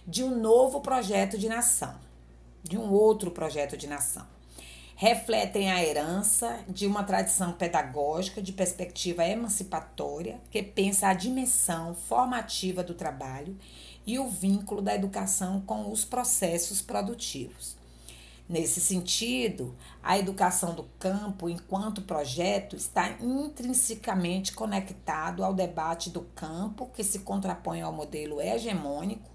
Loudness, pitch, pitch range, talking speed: -28 LUFS, 190 Hz, 160-215 Hz, 120 wpm